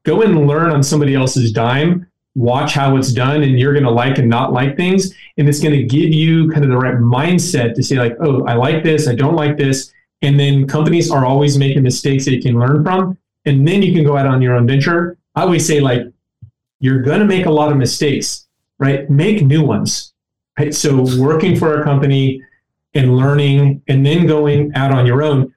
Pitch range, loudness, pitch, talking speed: 130-155 Hz, -13 LUFS, 140 Hz, 225 wpm